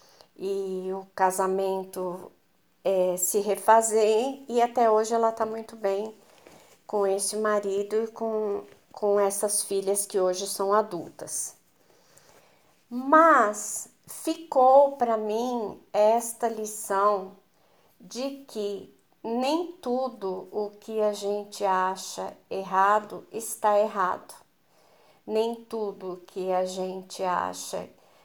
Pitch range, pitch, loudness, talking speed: 195-225 Hz, 210 Hz, -26 LUFS, 105 wpm